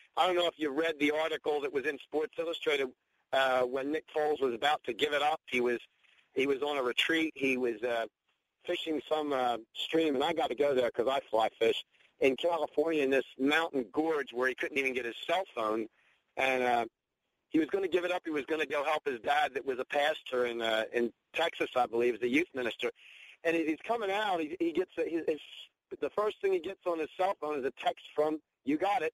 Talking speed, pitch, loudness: 245 wpm, 155 Hz, -32 LUFS